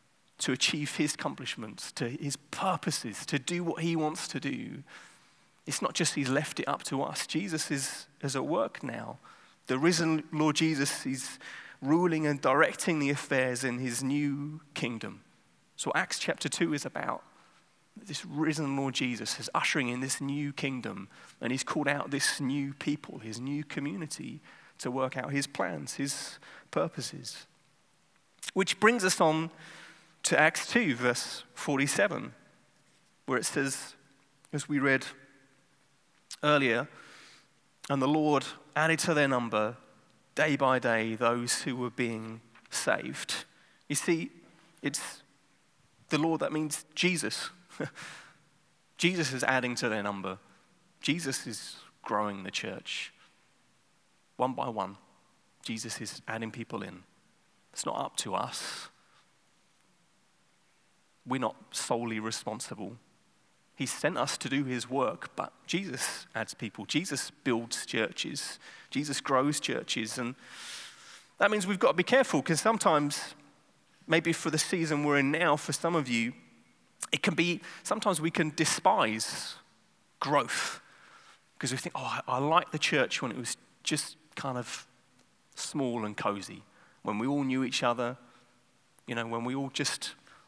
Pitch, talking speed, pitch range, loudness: 140 Hz, 145 wpm, 125-155 Hz, -31 LUFS